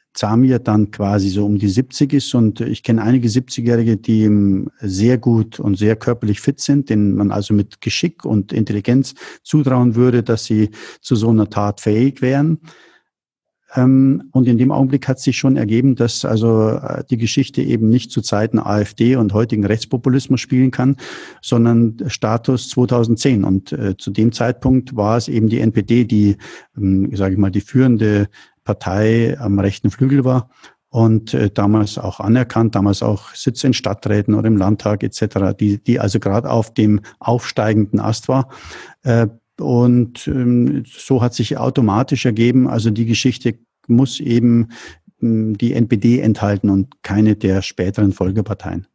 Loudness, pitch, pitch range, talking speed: -16 LUFS, 115 Hz, 105-130 Hz, 155 wpm